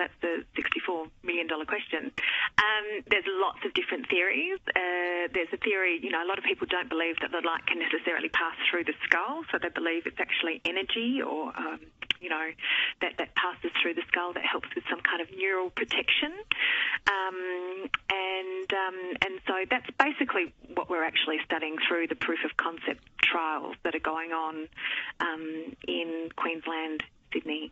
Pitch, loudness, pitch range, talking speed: 180 Hz, -29 LUFS, 165-220 Hz, 175 wpm